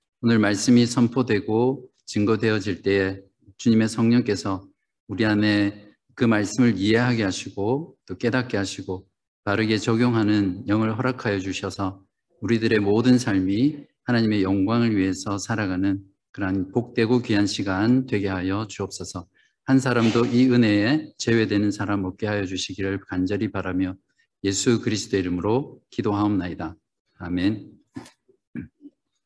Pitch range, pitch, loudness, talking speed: 95-115 Hz, 105 Hz, -23 LUFS, 300 characters per minute